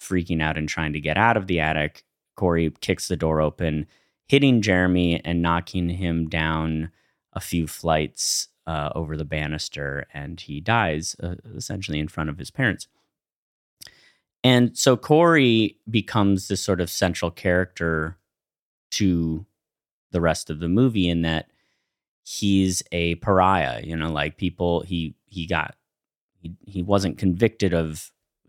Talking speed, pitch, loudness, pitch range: 145 wpm, 85 Hz, -23 LUFS, 80-95 Hz